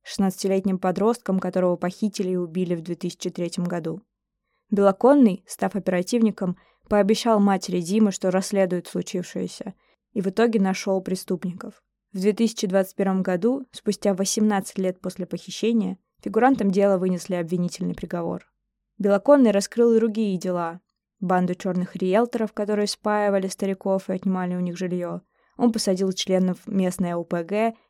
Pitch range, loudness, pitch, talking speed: 185-215 Hz, -23 LUFS, 195 Hz, 125 wpm